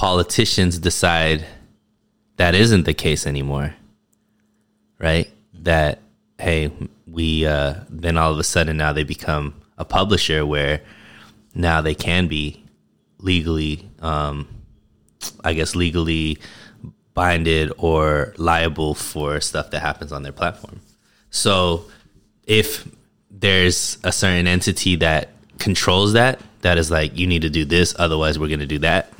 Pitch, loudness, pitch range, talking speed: 80 Hz, -19 LUFS, 75-90 Hz, 135 wpm